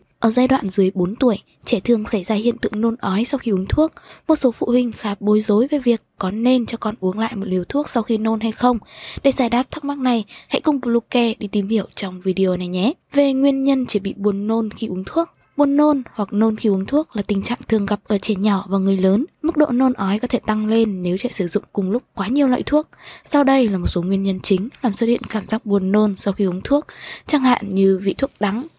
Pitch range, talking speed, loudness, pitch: 200-255 Hz, 265 wpm, -19 LUFS, 225 Hz